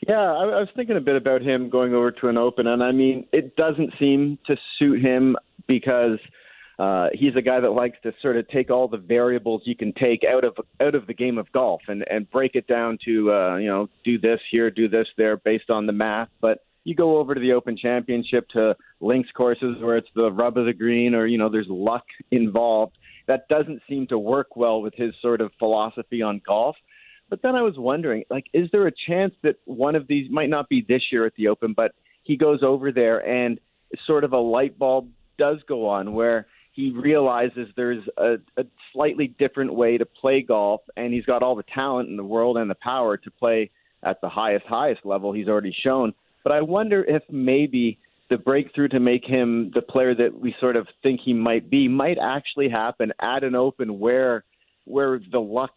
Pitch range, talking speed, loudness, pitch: 115-135 Hz, 220 wpm, -22 LUFS, 125 Hz